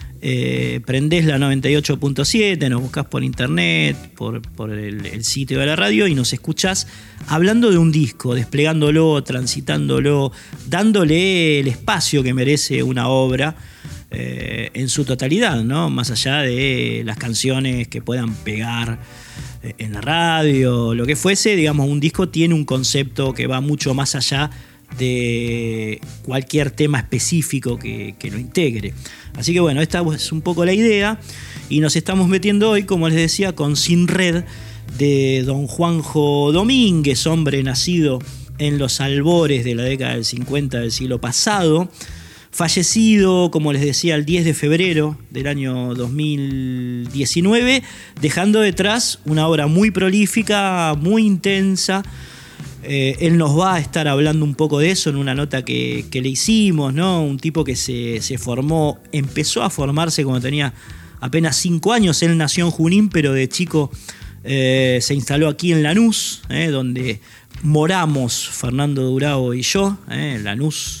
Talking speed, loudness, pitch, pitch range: 155 wpm, -17 LUFS, 145 Hz, 125-165 Hz